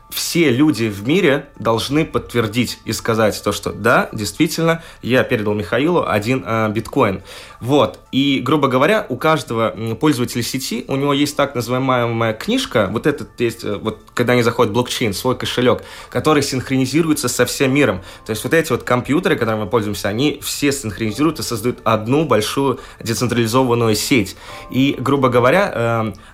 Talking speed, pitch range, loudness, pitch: 155 wpm, 110-140 Hz, -17 LUFS, 125 Hz